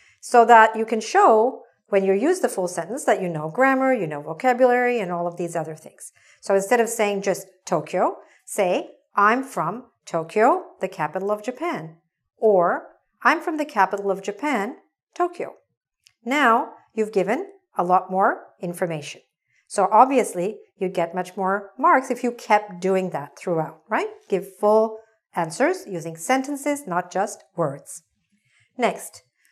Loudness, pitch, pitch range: -22 LUFS, 210 Hz, 185-255 Hz